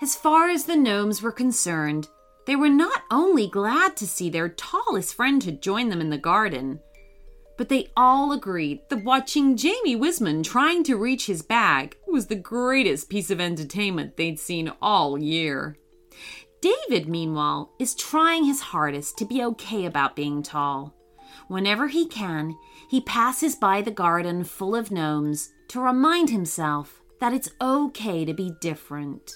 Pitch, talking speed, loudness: 200 Hz, 160 wpm, -23 LUFS